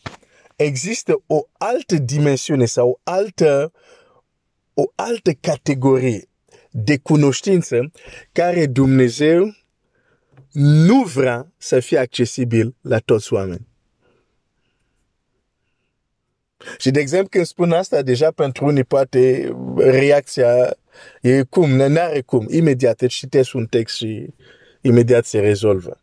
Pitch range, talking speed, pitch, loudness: 125-165 Hz, 115 wpm, 135 Hz, -17 LUFS